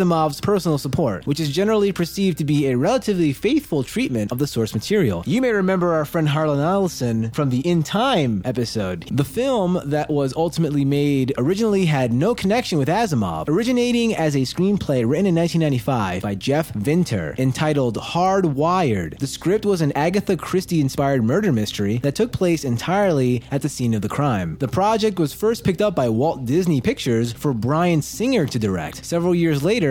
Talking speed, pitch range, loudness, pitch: 180 wpm, 130-185 Hz, -20 LUFS, 150 Hz